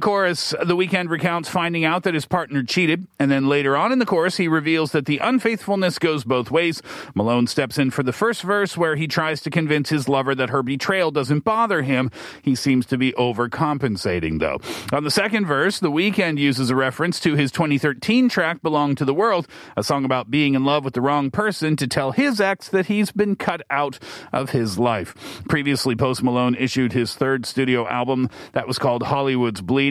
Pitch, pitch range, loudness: 145 Hz, 130-175 Hz, -20 LUFS